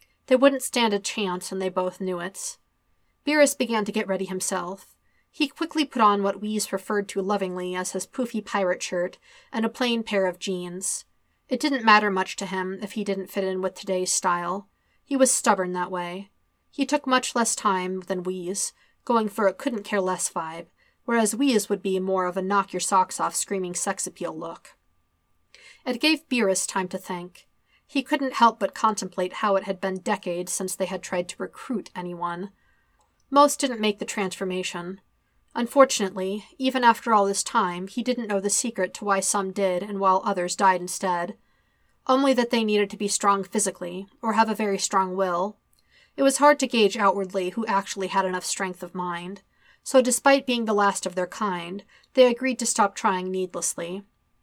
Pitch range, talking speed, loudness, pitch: 185-230 Hz, 190 wpm, -24 LUFS, 195 Hz